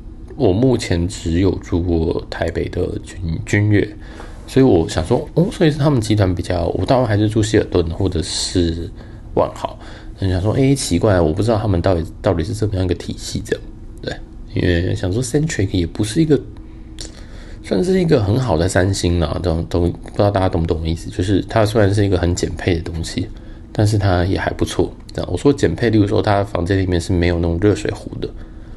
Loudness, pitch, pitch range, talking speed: -18 LUFS, 95 Hz, 85-110 Hz, 320 characters per minute